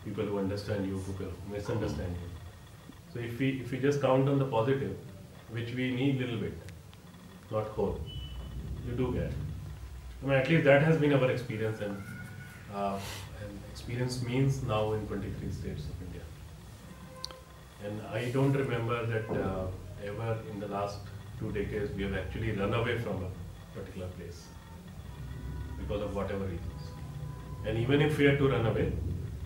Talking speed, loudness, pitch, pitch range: 165 wpm, -32 LUFS, 105 Hz, 95-120 Hz